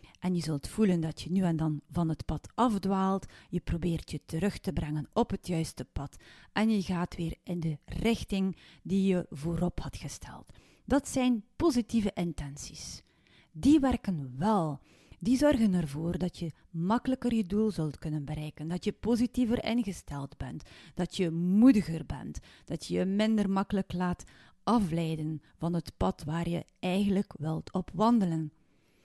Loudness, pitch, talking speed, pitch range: -31 LUFS, 180 Hz, 160 wpm, 160-210 Hz